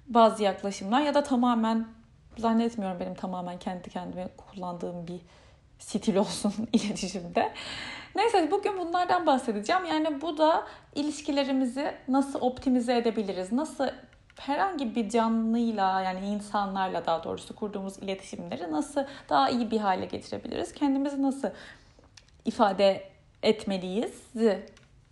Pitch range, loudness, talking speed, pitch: 195-275 Hz, -29 LUFS, 110 wpm, 225 Hz